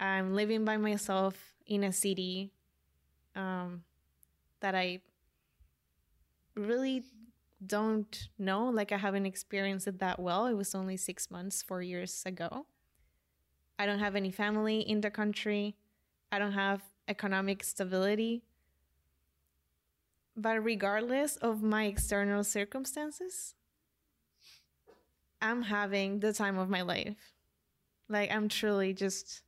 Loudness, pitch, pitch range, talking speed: -34 LUFS, 195 Hz, 180-210 Hz, 120 wpm